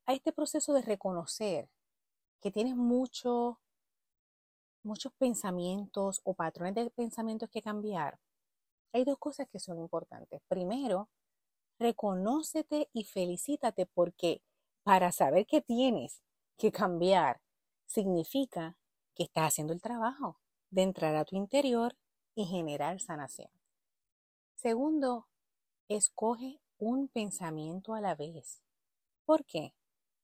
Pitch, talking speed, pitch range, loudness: 215 Hz, 110 wpm, 185-250 Hz, -34 LUFS